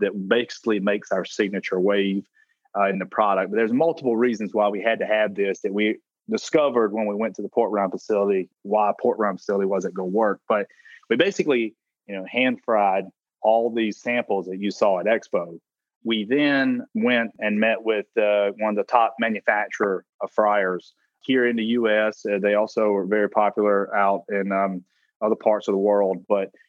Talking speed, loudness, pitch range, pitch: 195 wpm, -22 LUFS, 100-115 Hz, 105 Hz